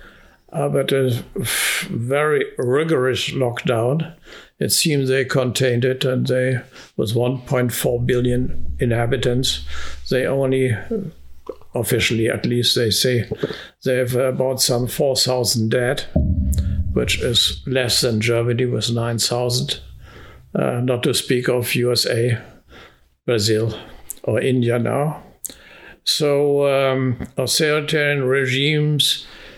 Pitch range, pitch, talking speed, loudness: 115-135 Hz, 125 Hz, 105 wpm, -19 LUFS